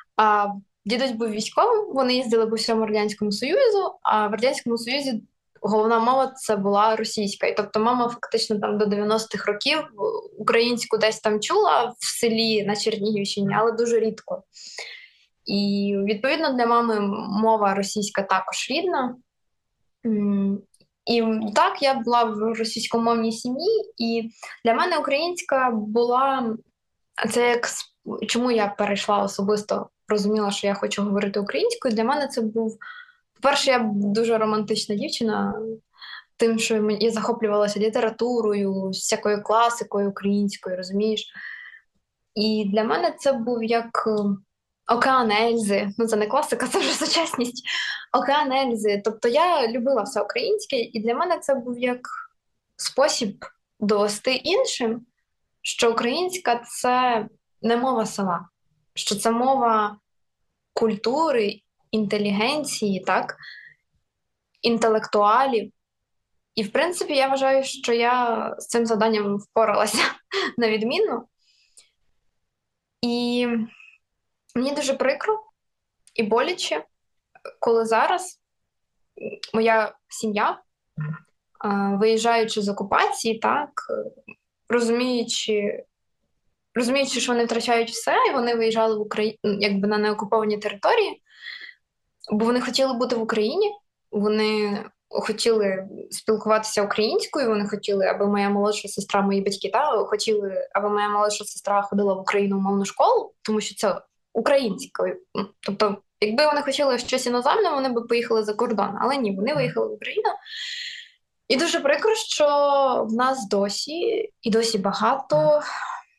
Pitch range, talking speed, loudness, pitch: 210-265 Hz, 120 wpm, -23 LUFS, 225 Hz